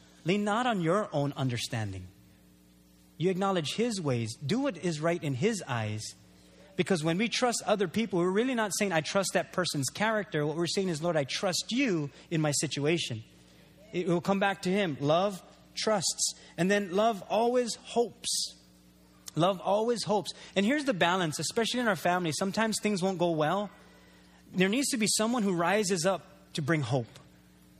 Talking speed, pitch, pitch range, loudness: 180 wpm, 180 Hz, 140-205 Hz, -29 LUFS